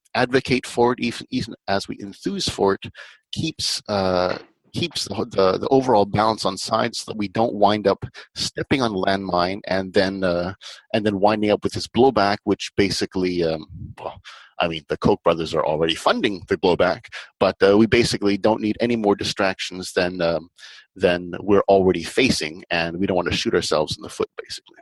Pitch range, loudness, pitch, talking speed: 95-115 Hz, -21 LUFS, 100 Hz, 190 wpm